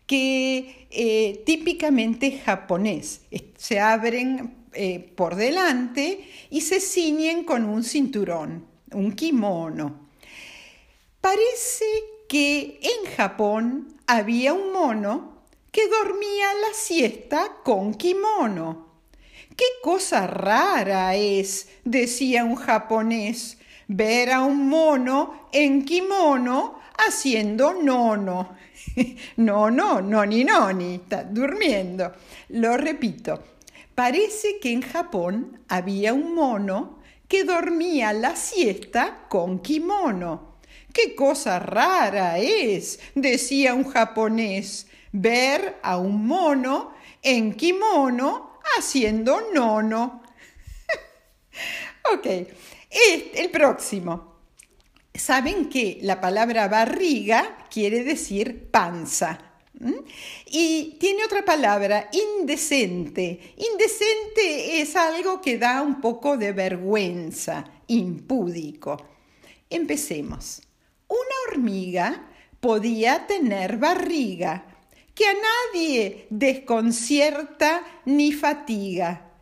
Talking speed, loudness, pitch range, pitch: 95 wpm, -23 LUFS, 210-320 Hz, 260 Hz